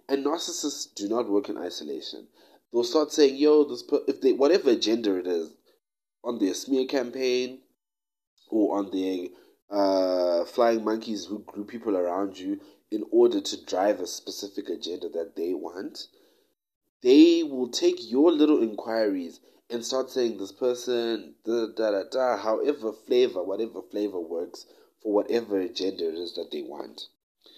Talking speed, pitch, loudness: 155 wpm, 150 Hz, -26 LUFS